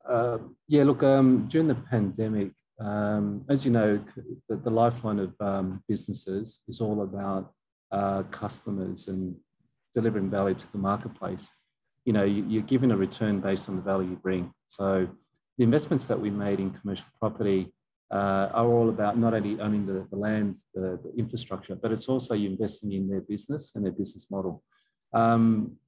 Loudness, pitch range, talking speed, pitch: -28 LUFS, 95-115 Hz, 175 wpm, 105 Hz